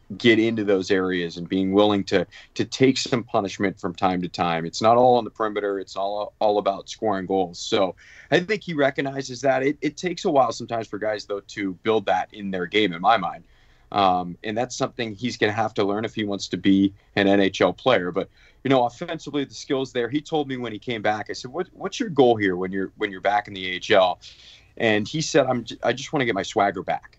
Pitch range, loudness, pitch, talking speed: 100-130 Hz, -23 LUFS, 110 Hz, 245 wpm